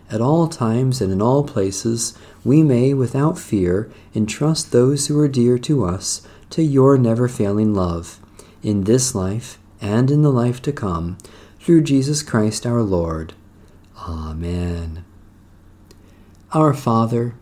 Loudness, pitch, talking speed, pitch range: -18 LUFS, 110 Hz, 140 wpm, 95-130 Hz